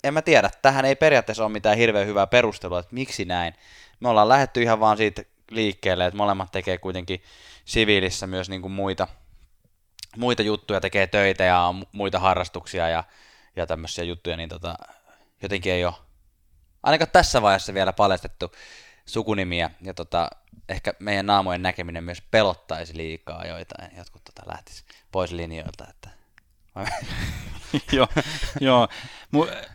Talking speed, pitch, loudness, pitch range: 140 wpm, 95 Hz, -23 LUFS, 85-105 Hz